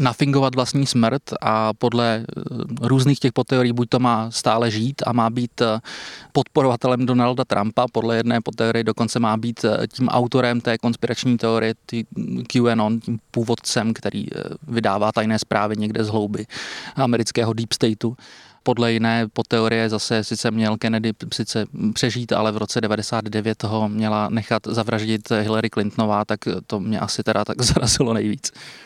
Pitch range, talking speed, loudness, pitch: 110-120 Hz, 150 wpm, -21 LUFS, 115 Hz